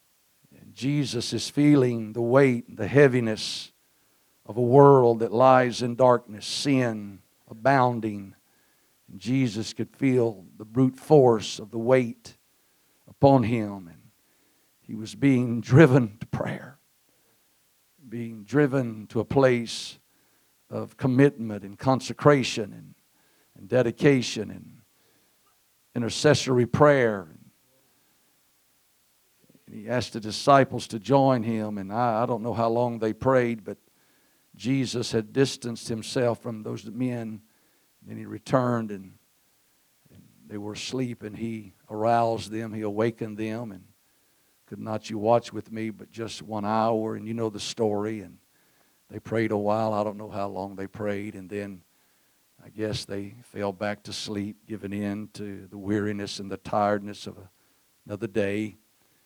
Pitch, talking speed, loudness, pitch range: 115 Hz, 140 wpm, -25 LUFS, 105-125 Hz